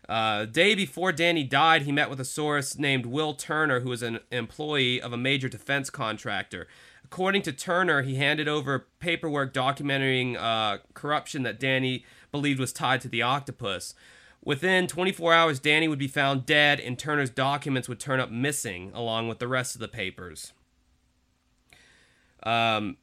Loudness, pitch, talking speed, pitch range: -26 LUFS, 135 Hz, 165 wpm, 120-150 Hz